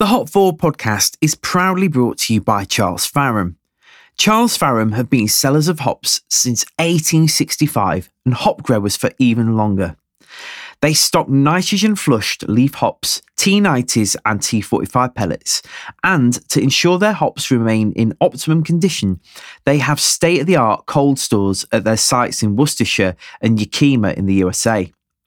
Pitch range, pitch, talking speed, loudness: 110-155 Hz, 125 Hz, 140 wpm, -15 LUFS